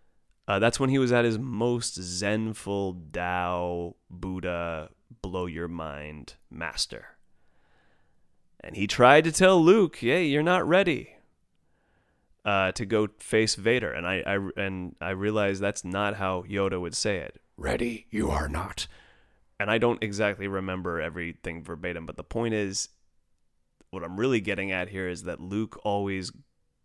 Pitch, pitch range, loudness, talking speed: 95 Hz, 85-110 Hz, -27 LUFS, 150 wpm